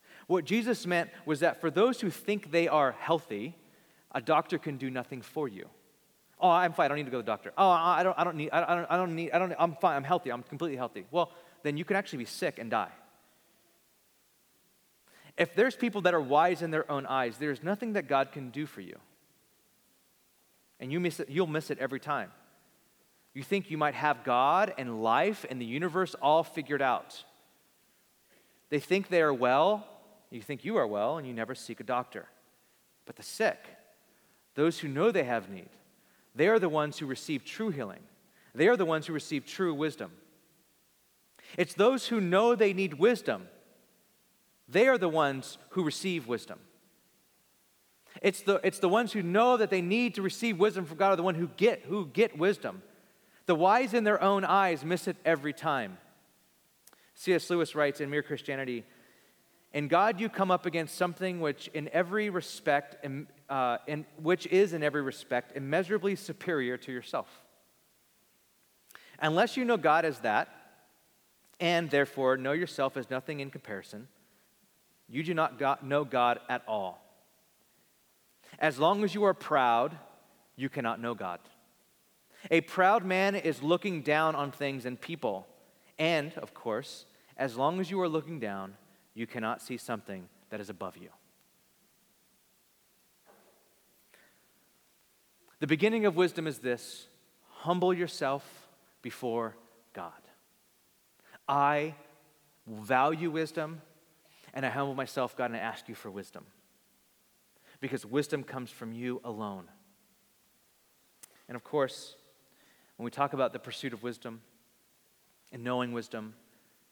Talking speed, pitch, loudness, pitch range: 165 wpm, 155 Hz, -30 LUFS, 135-185 Hz